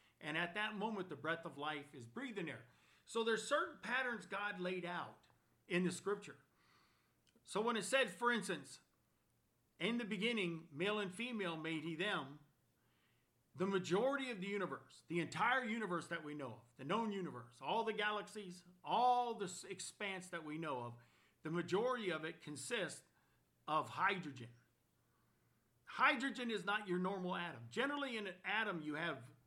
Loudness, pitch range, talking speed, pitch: -41 LUFS, 150-210 Hz, 165 wpm, 180 Hz